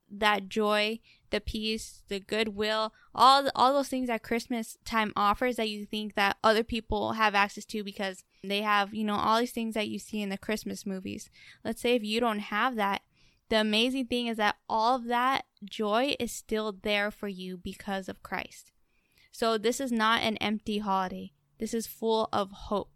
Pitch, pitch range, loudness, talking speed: 215 Hz, 205-230 Hz, -29 LUFS, 195 wpm